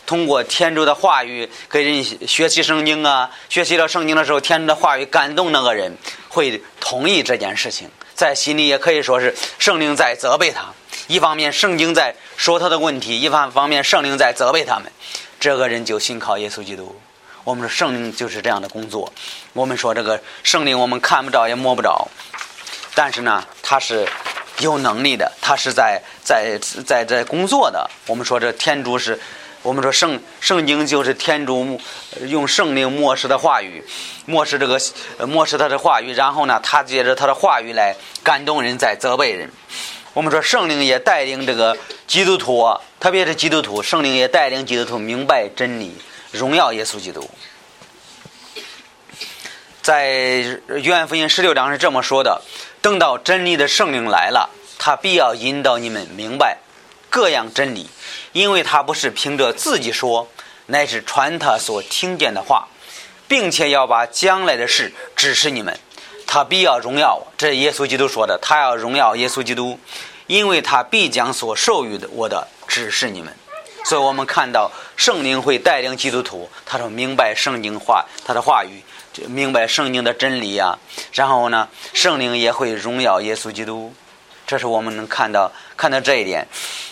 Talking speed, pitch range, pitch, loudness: 265 characters per minute, 120-155 Hz, 135 Hz, -16 LUFS